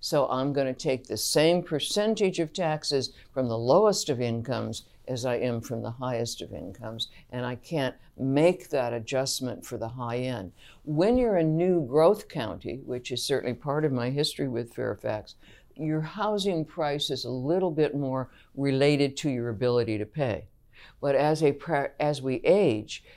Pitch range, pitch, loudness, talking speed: 120-155 Hz, 135 Hz, -27 LUFS, 175 wpm